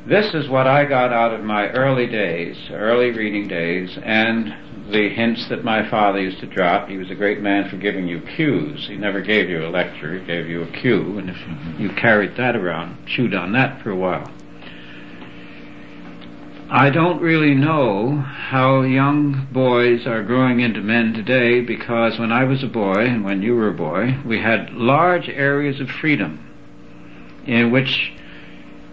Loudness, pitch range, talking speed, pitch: -18 LUFS, 95-130 Hz, 180 wpm, 115 Hz